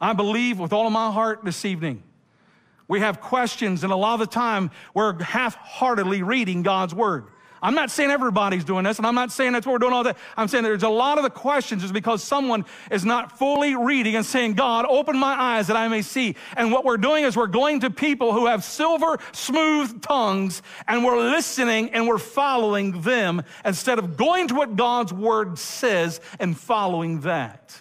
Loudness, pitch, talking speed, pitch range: -22 LUFS, 230 Hz, 205 wpm, 205-255 Hz